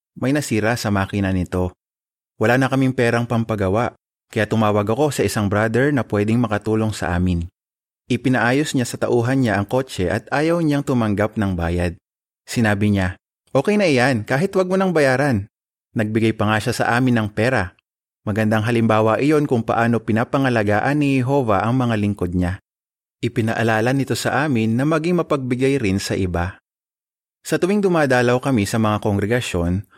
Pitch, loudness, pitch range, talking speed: 115 Hz, -19 LUFS, 105-130 Hz, 160 wpm